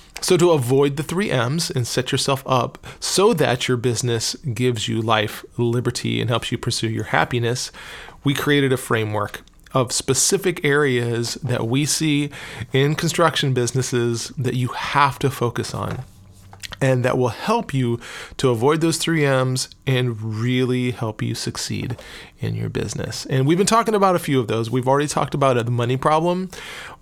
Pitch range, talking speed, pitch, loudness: 120-145 Hz, 170 wpm, 130 Hz, -20 LUFS